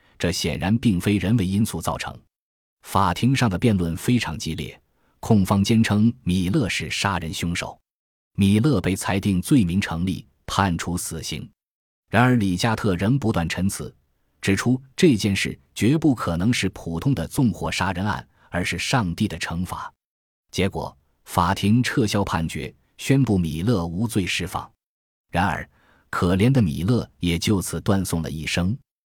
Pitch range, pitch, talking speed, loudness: 85-115 Hz, 100 Hz, 230 characters per minute, -22 LUFS